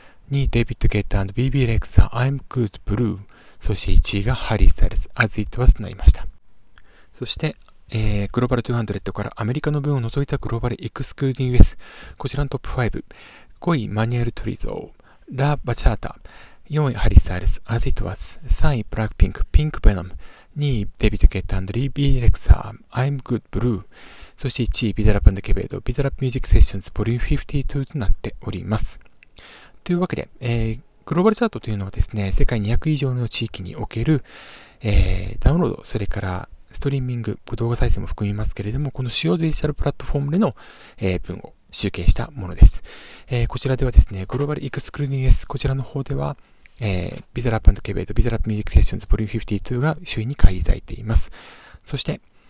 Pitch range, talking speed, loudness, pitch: 100-130 Hz, 445 characters per minute, -22 LUFS, 115 Hz